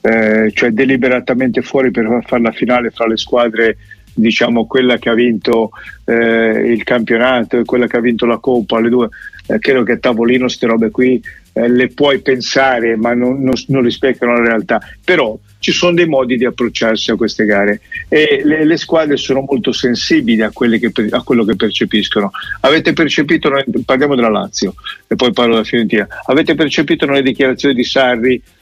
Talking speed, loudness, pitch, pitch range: 180 wpm, -13 LUFS, 120 Hz, 115-135 Hz